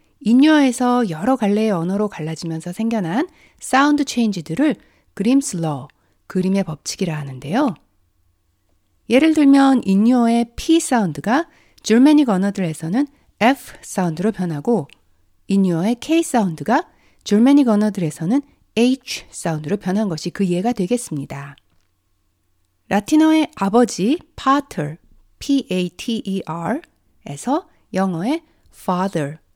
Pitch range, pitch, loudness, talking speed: 160-255 Hz, 205 Hz, -18 LUFS, 280 characters per minute